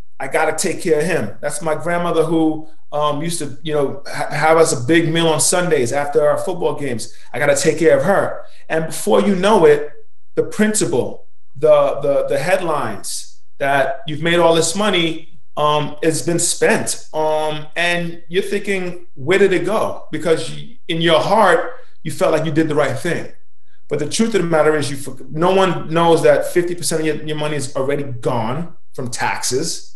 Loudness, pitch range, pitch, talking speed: -17 LUFS, 150-175 Hz, 160 Hz, 195 wpm